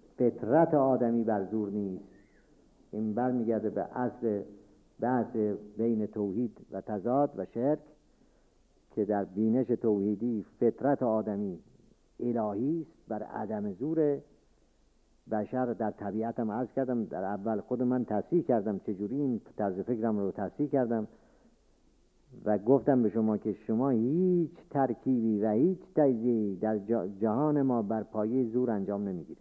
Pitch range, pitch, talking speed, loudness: 105-125 Hz, 115 Hz, 130 wpm, -31 LUFS